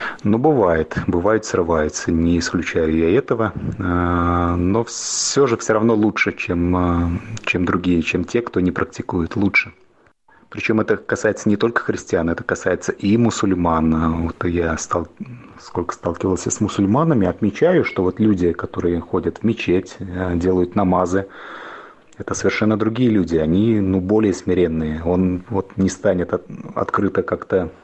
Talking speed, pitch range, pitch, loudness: 140 wpm, 85-105 Hz, 90 Hz, -19 LUFS